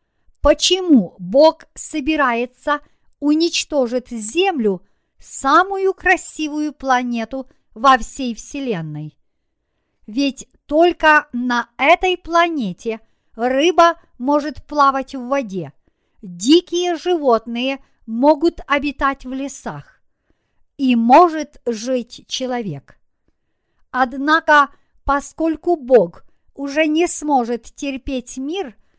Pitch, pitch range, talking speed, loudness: 275 Hz, 245-315 Hz, 80 wpm, -17 LUFS